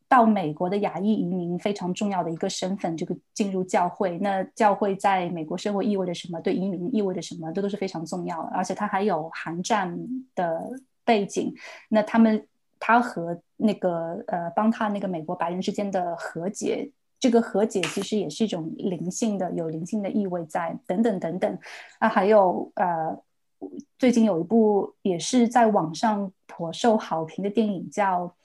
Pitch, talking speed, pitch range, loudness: 195 Hz, 275 characters per minute, 180-220 Hz, -25 LUFS